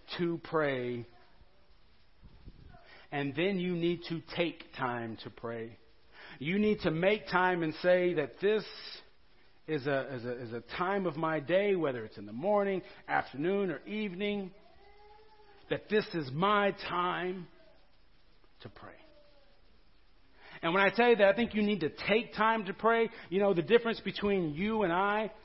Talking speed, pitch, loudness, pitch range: 160 wpm, 185 Hz, -31 LUFS, 160-210 Hz